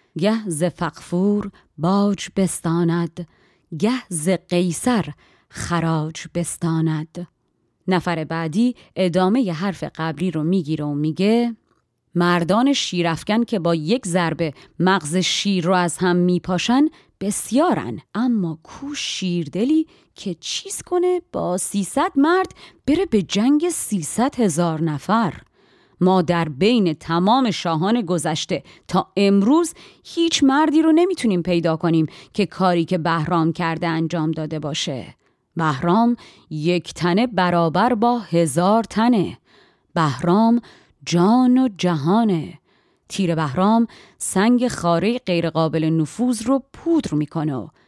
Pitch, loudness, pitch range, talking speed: 180 Hz, -20 LUFS, 165-230 Hz, 115 wpm